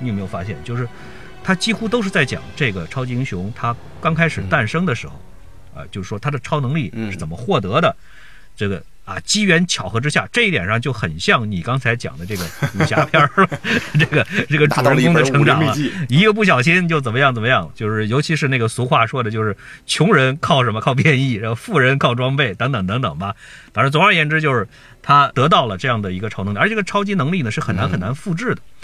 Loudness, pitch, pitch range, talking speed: -17 LUFS, 135 Hz, 115-155 Hz, 345 characters per minute